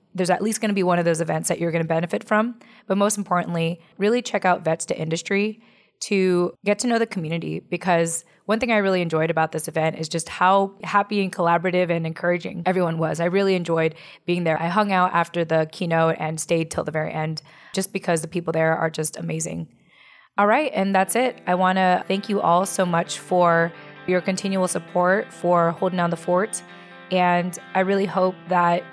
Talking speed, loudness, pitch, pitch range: 210 wpm, -22 LUFS, 175 Hz, 165-190 Hz